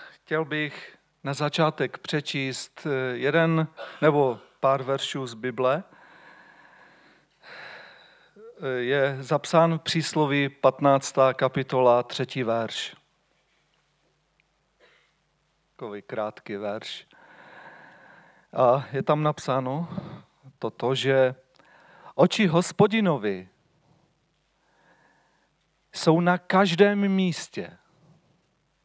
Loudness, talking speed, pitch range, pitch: -25 LUFS, 70 wpm, 130-165 Hz, 140 Hz